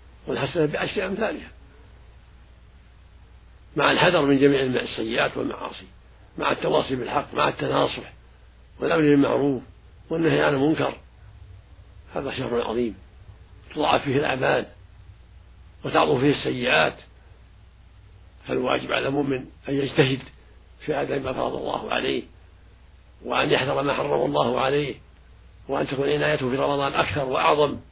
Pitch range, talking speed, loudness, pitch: 90-140 Hz, 110 wpm, -23 LUFS, 105 Hz